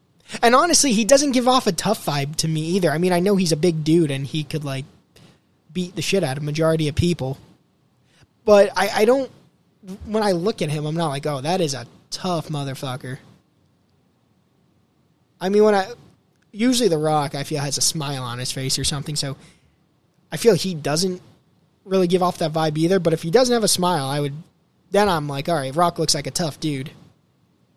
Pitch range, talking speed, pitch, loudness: 150-190 Hz, 210 wpm, 165 Hz, -20 LUFS